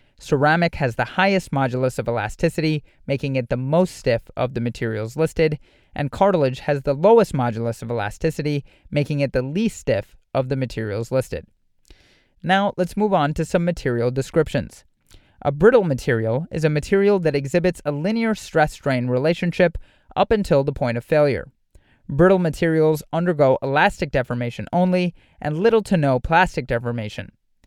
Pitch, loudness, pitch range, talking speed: 145 Hz, -21 LUFS, 125-175 Hz, 155 wpm